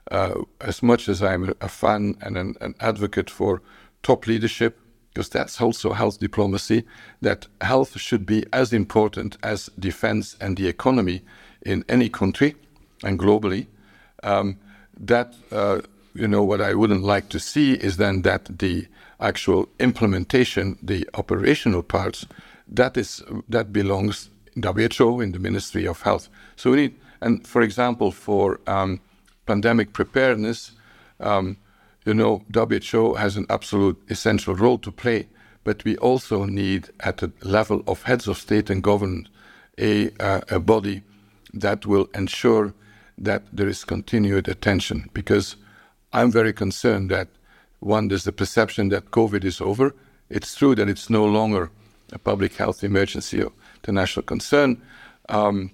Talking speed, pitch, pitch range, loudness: 155 wpm, 105 Hz, 100-115 Hz, -22 LUFS